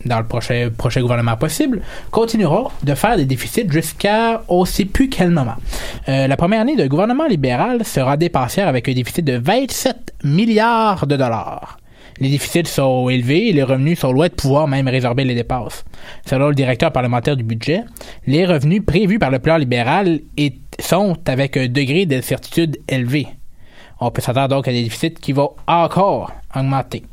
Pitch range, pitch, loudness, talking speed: 130-175 Hz, 140 Hz, -17 LUFS, 175 wpm